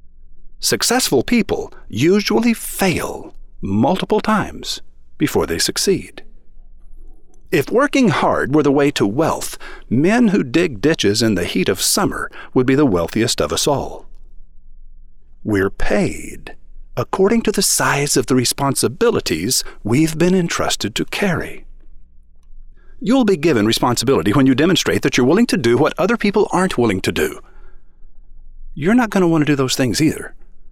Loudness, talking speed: -16 LUFS, 150 wpm